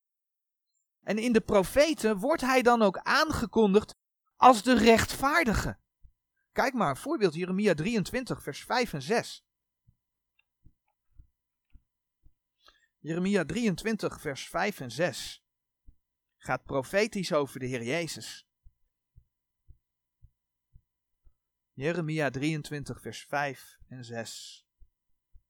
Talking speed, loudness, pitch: 95 wpm, -28 LUFS, 175 Hz